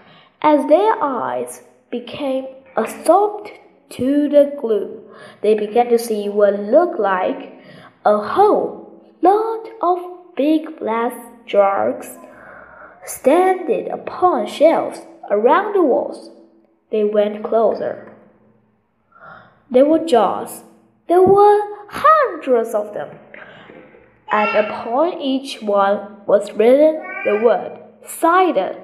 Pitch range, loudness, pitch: 215-355 Hz, -17 LUFS, 270 Hz